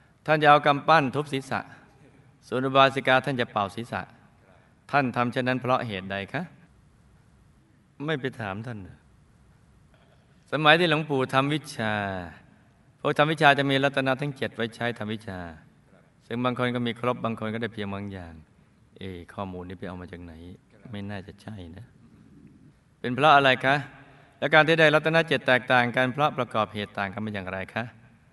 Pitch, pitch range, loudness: 125 Hz, 105-140 Hz, -24 LUFS